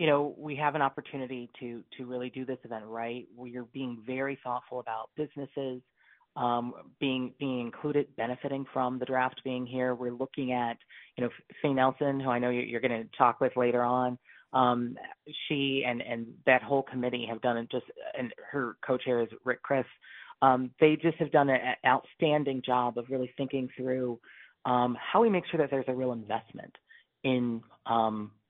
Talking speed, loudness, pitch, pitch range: 185 wpm, -31 LUFS, 125 Hz, 120-135 Hz